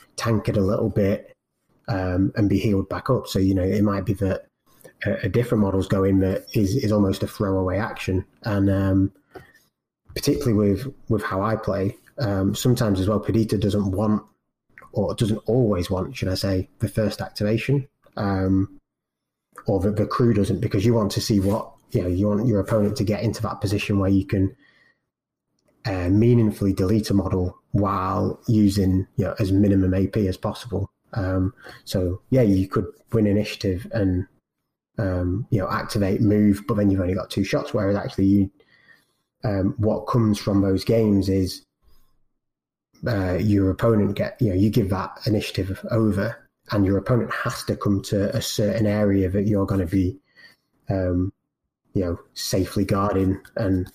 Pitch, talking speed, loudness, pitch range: 100 Hz, 175 wpm, -23 LUFS, 95-110 Hz